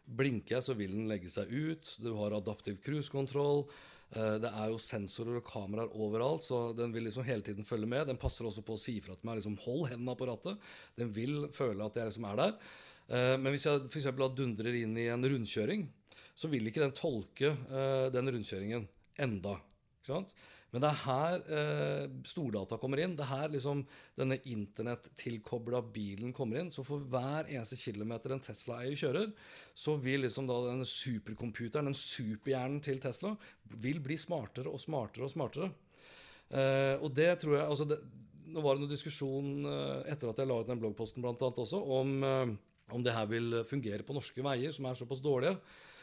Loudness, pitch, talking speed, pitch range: -37 LUFS, 125 Hz, 190 wpm, 115-140 Hz